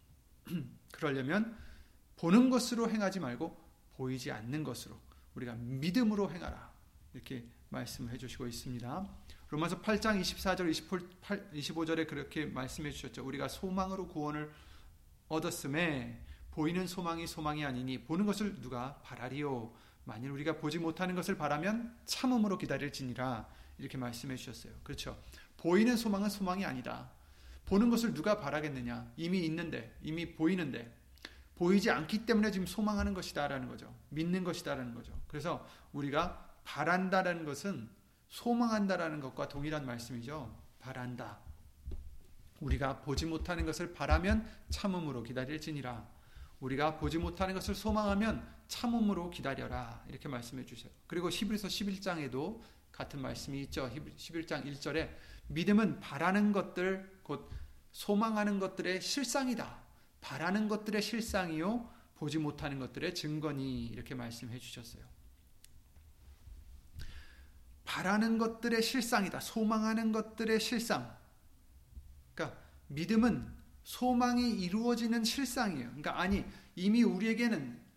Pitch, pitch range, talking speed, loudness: 160 Hz, 125-200 Hz, 310 characters per minute, -36 LUFS